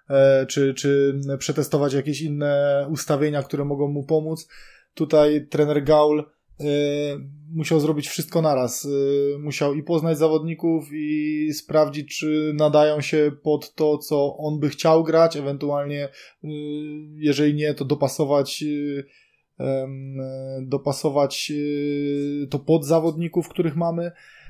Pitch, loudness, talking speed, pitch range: 150 Hz, -22 LUFS, 110 wpm, 145-155 Hz